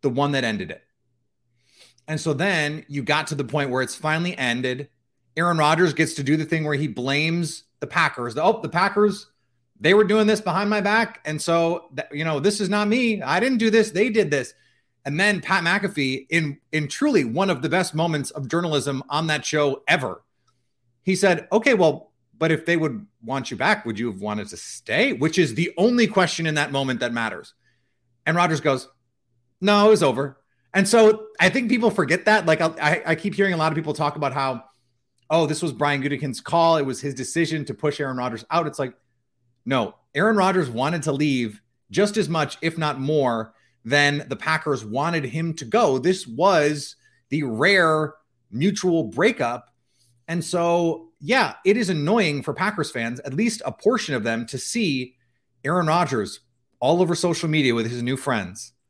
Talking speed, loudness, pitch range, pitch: 195 wpm, -22 LUFS, 130-175 Hz, 150 Hz